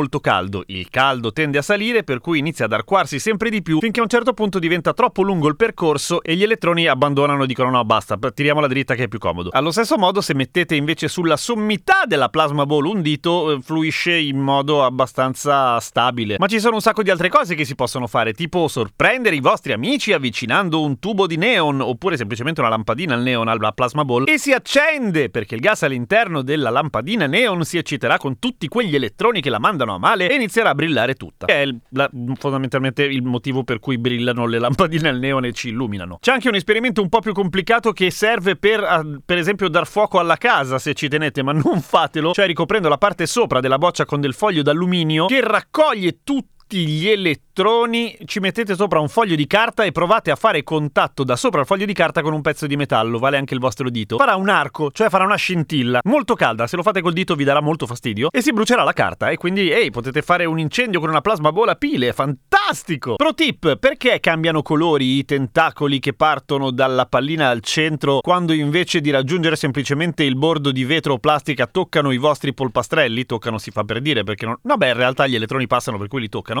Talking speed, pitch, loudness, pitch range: 220 wpm, 155 Hz, -18 LUFS, 135-195 Hz